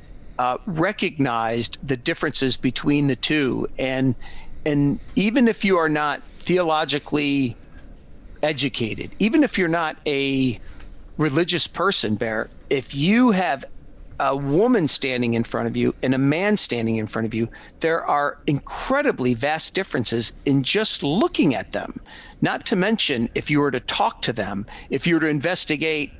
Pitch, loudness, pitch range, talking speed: 140 Hz, -21 LUFS, 120-165 Hz, 155 wpm